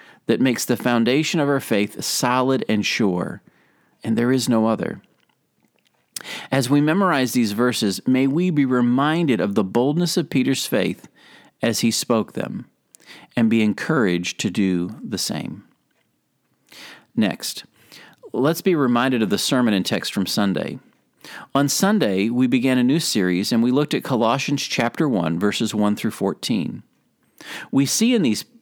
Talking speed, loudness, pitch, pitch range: 155 wpm, -20 LUFS, 125 Hz, 110-140 Hz